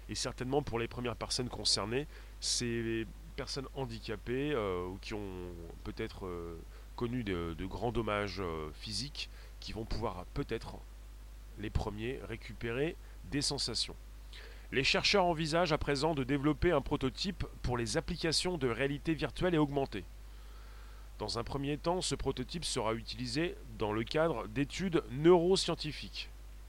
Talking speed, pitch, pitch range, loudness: 140 wpm, 120 Hz, 105-145 Hz, -35 LUFS